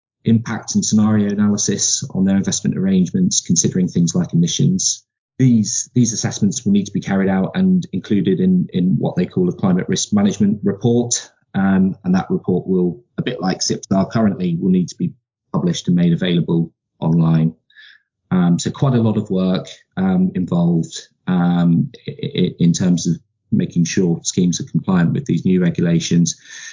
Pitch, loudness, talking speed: 175 Hz, -17 LUFS, 165 wpm